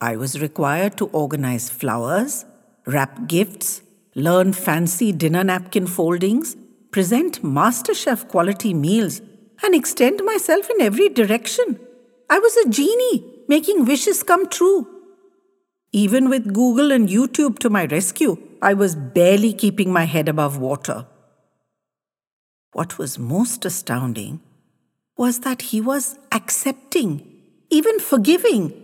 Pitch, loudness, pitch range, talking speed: 220 Hz, -19 LUFS, 180-275 Hz, 120 wpm